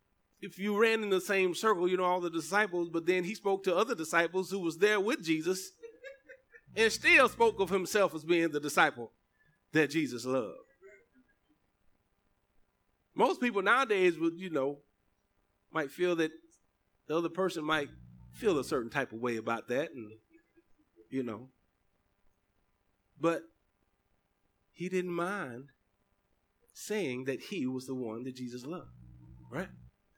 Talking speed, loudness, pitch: 145 wpm, -31 LUFS, 155 Hz